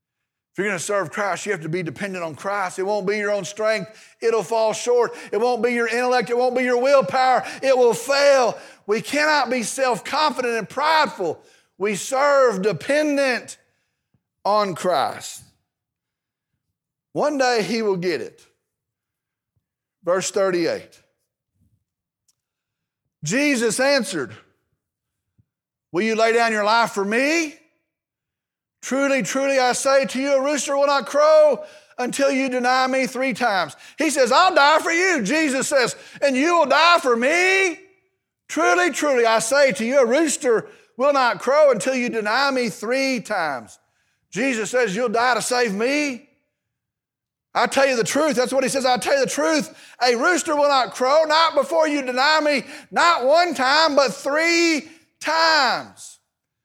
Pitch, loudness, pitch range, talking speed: 260 Hz, -19 LUFS, 225-295 Hz, 160 wpm